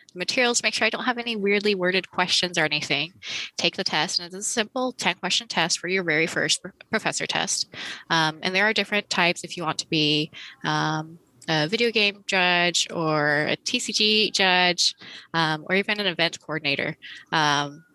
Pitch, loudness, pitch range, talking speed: 180 Hz, -23 LUFS, 155-205 Hz, 185 wpm